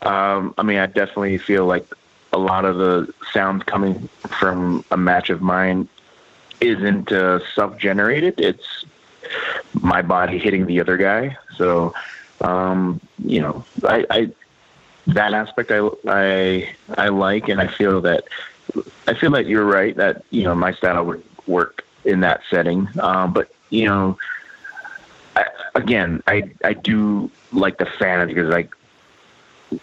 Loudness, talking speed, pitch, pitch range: -19 LUFS, 150 wpm, 95 Hz, 90-100 Hz